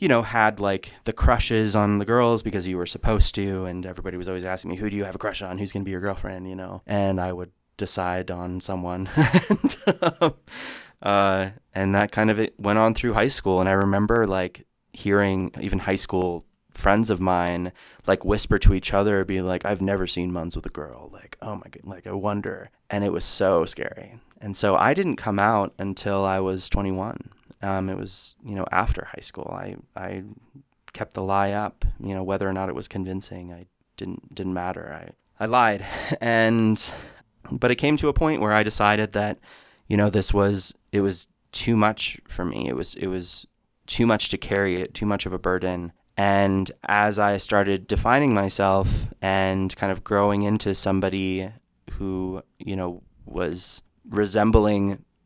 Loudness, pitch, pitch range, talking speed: -24 LUFS, 100 Hz, 95-105 Hz, 195 wpm